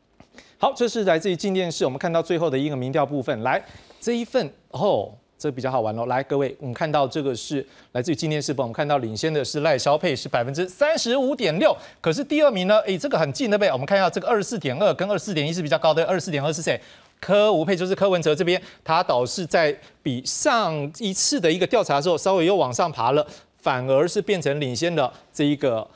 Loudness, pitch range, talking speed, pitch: -22 LUFS, 140-200 Hz, 365 characters per minute, 160 Hz